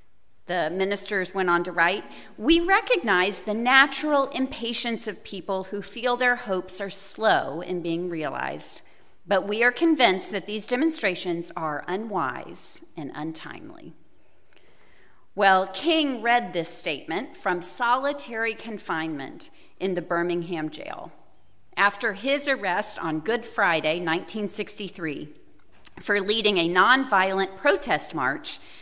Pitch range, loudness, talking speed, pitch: 175-235 Hz, -24 LUFS, 120 wpm, 195 Hz